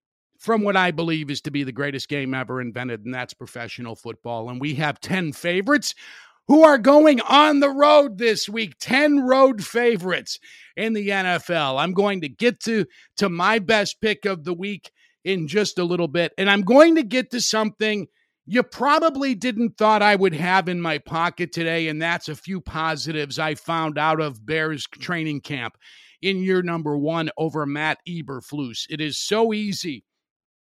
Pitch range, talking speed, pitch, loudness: 155-220 Hz, 180 wpm, 175 Hz, -21 LUFS